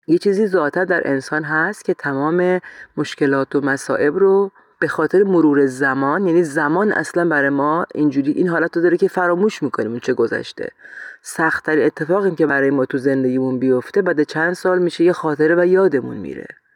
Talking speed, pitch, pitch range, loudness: 175 wpm, 165 Hz, 140-185 Hz, -17 LUFS